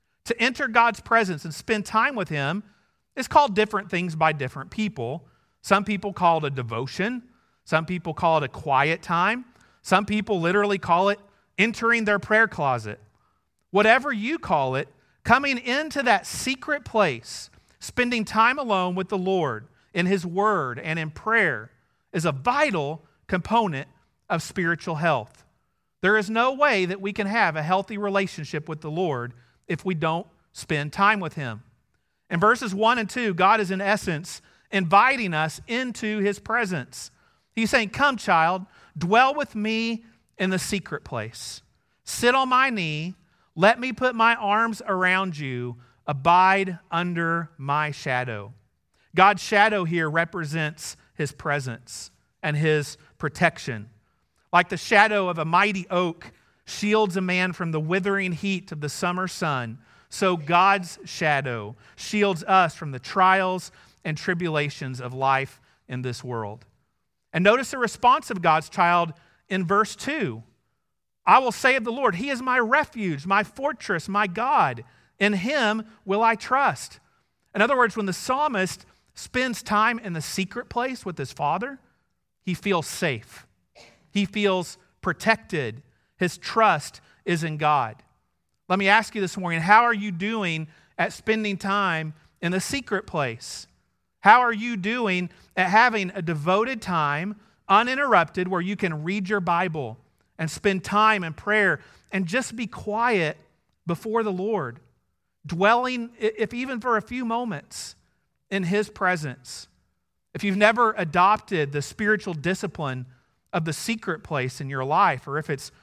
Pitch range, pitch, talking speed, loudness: 155-215 Hz, 185 Hz, 155 wpm, -23 LUFS